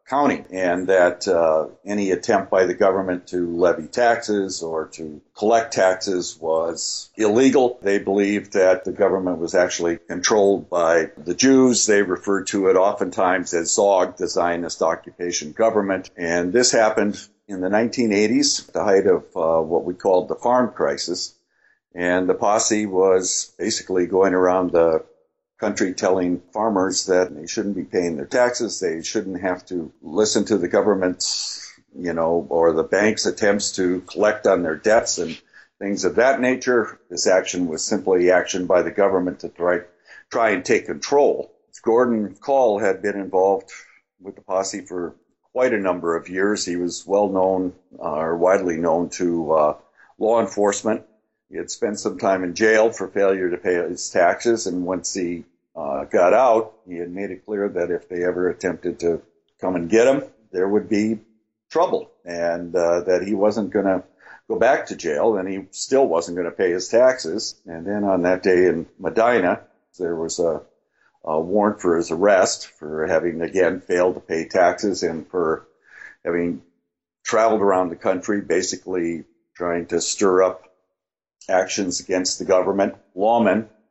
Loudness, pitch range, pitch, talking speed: -20 LUFS, 90-105 Hz, 95 Hz, 170 wpm